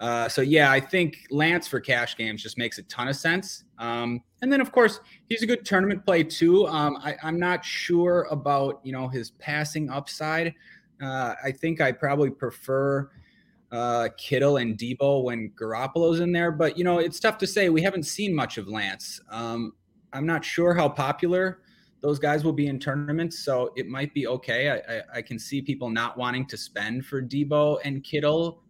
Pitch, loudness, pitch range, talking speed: 145 Hz, -25 LUFS, 125-170 Hz, 200 wpm